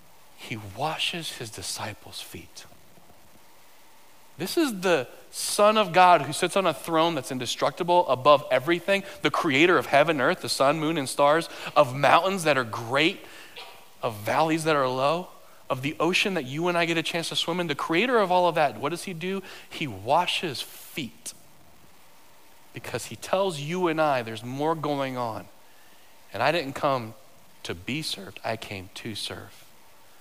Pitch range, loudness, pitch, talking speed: 130-175 Hz, -25 LUFS, 155 Hz, 175 wpm